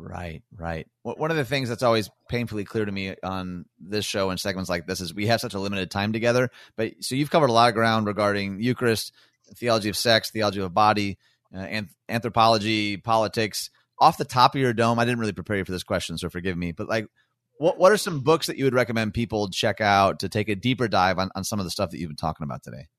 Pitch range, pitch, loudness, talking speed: 95-115 Hz, 105 Hz, -24 LUFS, 250 wpm